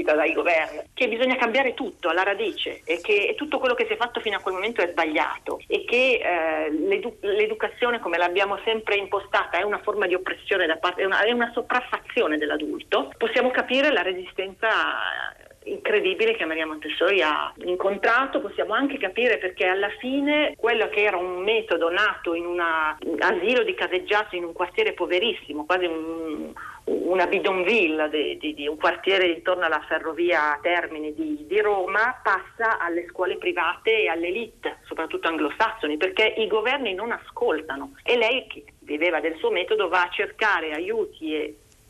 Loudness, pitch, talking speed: -23 LUFS, 210 Hz, 165 wpm